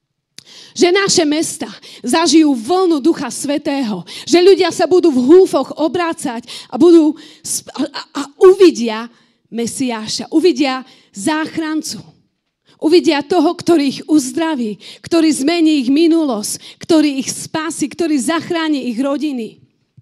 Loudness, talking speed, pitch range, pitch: -14 LUFS, 115 wpm, 260-330 Hz, 305 Hz